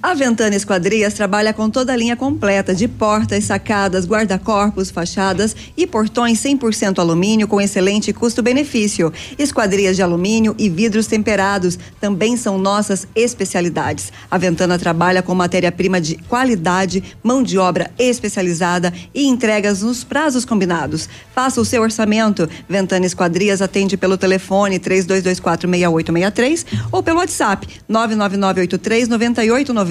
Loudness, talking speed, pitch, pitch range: -16 LUFS, 120 wpm, 205 Hz, 185-225 Hz